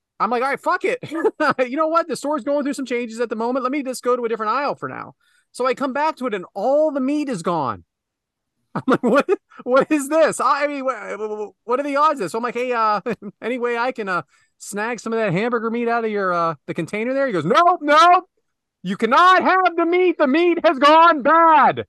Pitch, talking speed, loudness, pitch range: 260 Hz, 255 wpm, -19 LUFS, 230-315 Hz